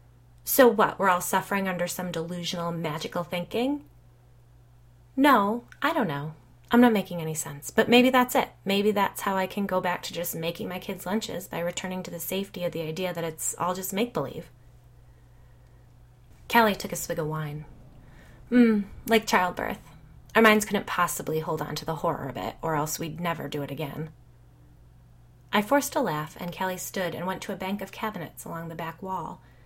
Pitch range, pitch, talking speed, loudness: 145-200 Hz, 175 Hz, 190 wpm, -26 LUFS